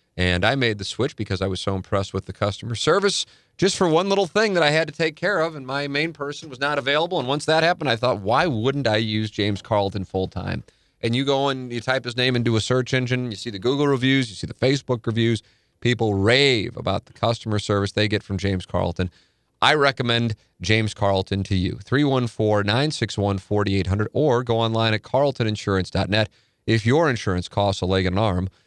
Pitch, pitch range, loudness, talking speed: 115 Hz, 100-135 Hz, -22 LUFS, 215 wpm